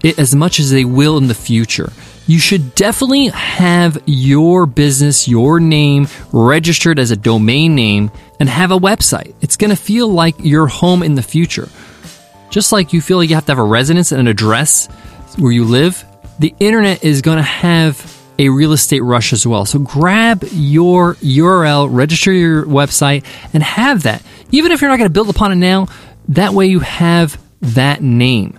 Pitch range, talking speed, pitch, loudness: 130-180 Hz, 190 wpm, 155 Hz, -11 LUFS